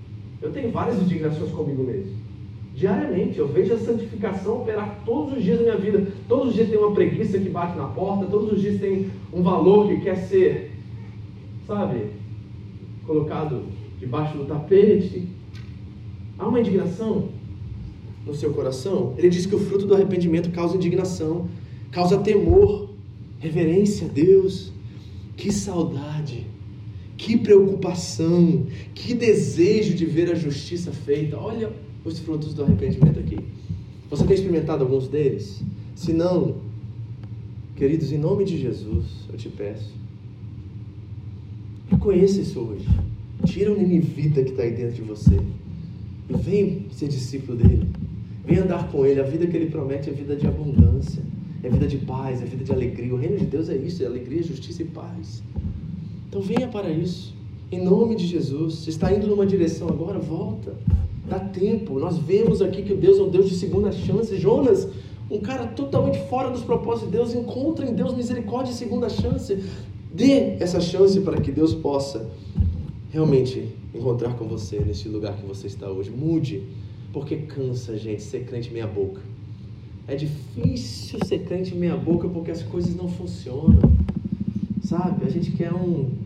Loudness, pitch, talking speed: -23 LUFS, 145 Hz, 160 wpm